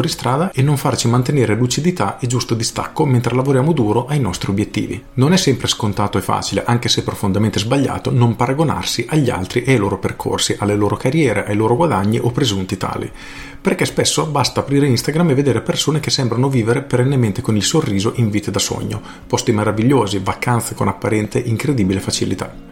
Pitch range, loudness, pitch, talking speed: 105-135 Hz, -17 LUFS, 120 Hz, 180 wpm